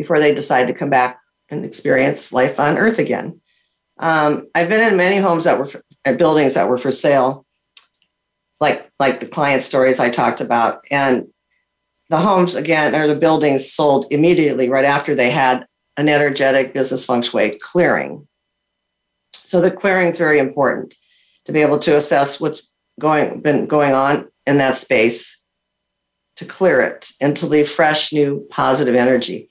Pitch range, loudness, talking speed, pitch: 130-155 Hz, -16 LUFS, 170 wpm, 145 Hz